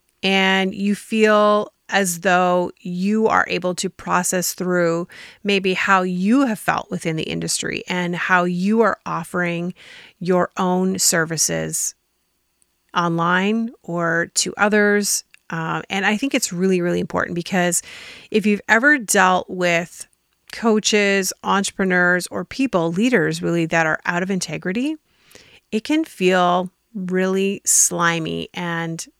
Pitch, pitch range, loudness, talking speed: 185 Hz, 175-205 Hz, -19 LUFS, 125 wpm